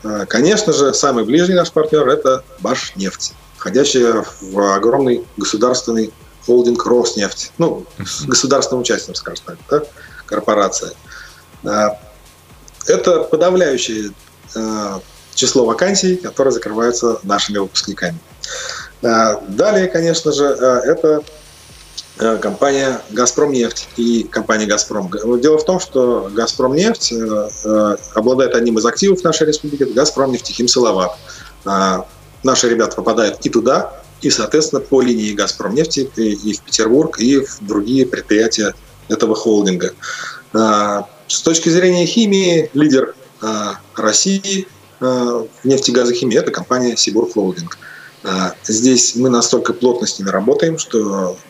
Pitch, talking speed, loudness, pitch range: 120 Hz, 110 wpm, -15 LUFS, 105-140 Hz